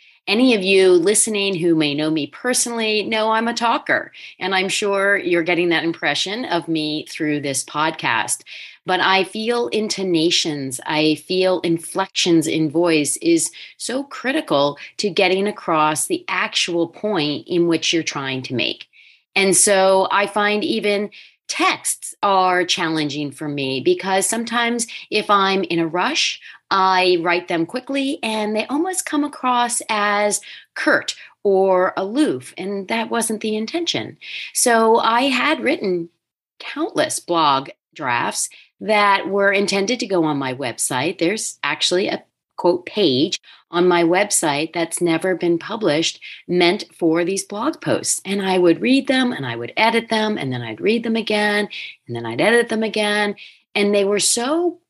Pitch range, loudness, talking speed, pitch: 170-225 Hz, -19 LUFS, 155 wpm, 195 Hz